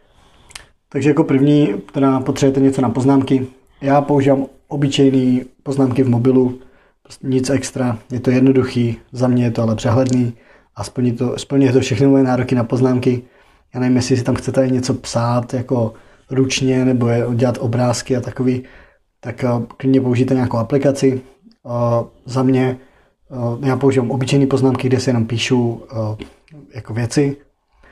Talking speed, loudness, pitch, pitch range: 145 wpm, -17 LUFS, 130 Hz, 125-135 Hz